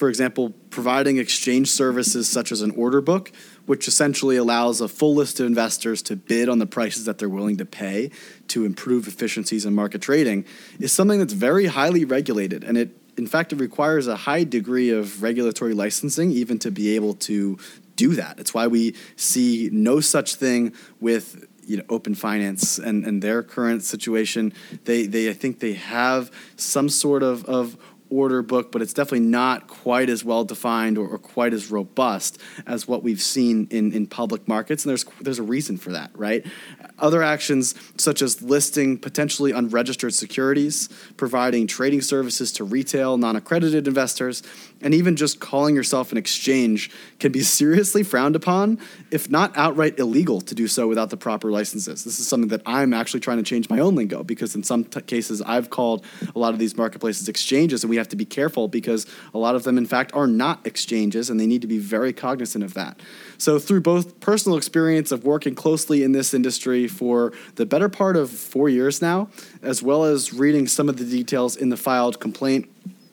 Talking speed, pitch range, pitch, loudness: 195 wpm, 115-145 Hz, 125 Hz, -21 LUFS